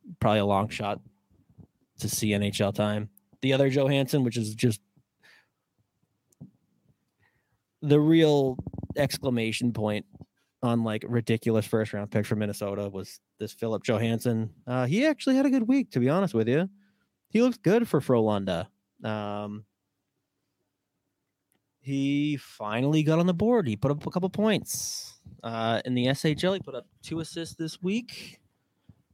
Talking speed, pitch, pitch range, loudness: 145 wpm, 125 Hz, 105-160 Hz, -27 LUFS